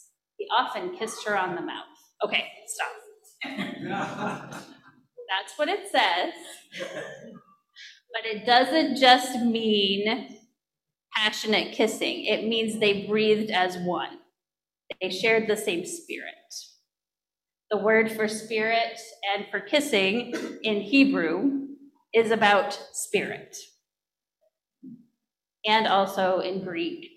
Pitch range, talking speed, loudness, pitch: 210-280 Hz, 105 wpm, -25 LUFS, 225 Hz